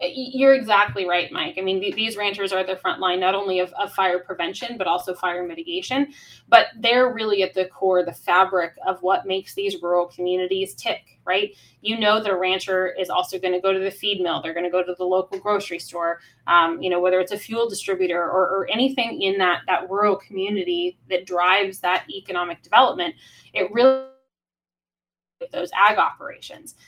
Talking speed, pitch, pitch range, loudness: 190 wpm, 190 Hz, 180-205 Hz, -22 LUFS